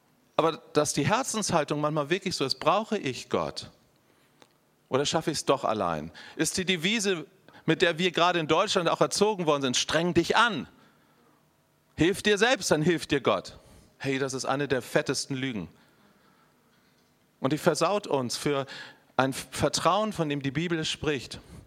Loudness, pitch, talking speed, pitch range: -27 LUFS, 160 Hz, 165 wpm, 140-180 Hz